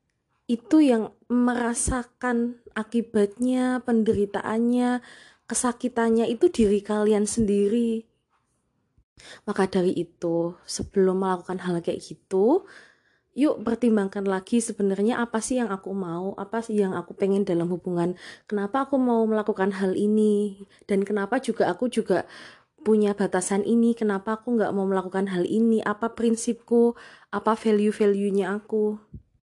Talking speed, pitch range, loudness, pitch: 120 wpm, 195-235 Hz, -24 LUFS, 215 Hz